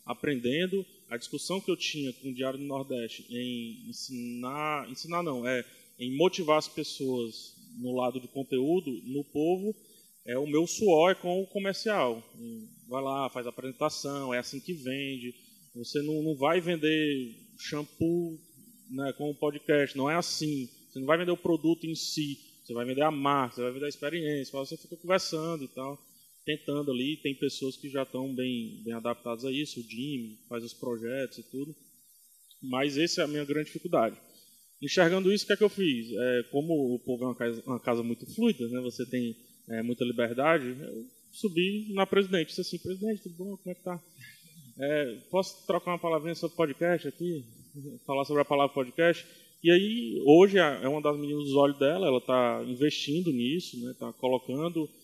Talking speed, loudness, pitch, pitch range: 190 wpm, -30 LUFS, 145 Hz, 130-170 Hz